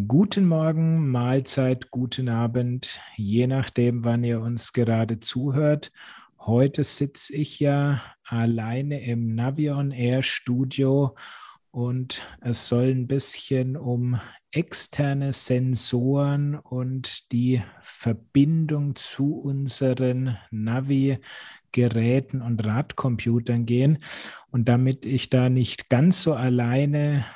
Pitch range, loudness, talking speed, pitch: 120-140 Hz, -24 LUFS, 105 wpm, 130 Hz